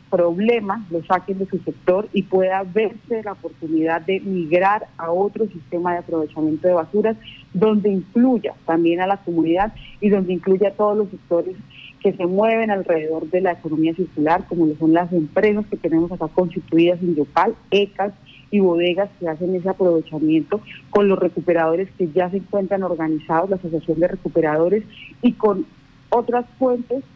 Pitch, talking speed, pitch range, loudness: 180 Hz, 165 wpm, 165-200 Hz, -20 LUFS